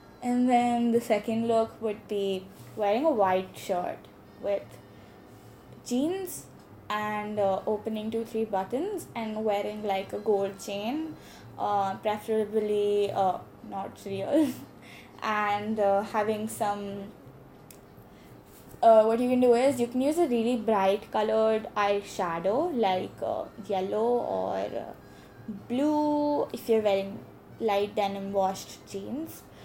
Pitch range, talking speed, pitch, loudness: 200-235 Hz, 125 wpm, 215 Hz, -28 LUFS